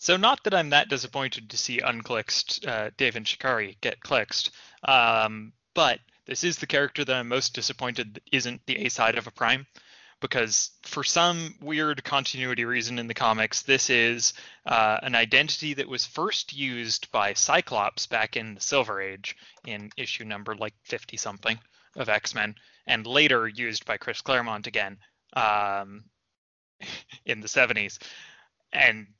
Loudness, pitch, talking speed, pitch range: -25 LUFS, 120 Hz, 160 wpm, 110-140 Hz